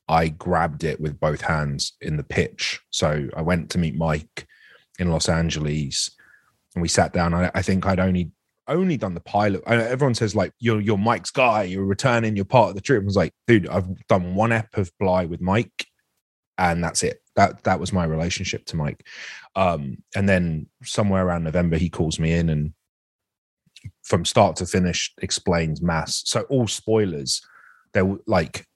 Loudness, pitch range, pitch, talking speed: -22 LUFS, 80-105 Hz, 90 Hz, 190 wpm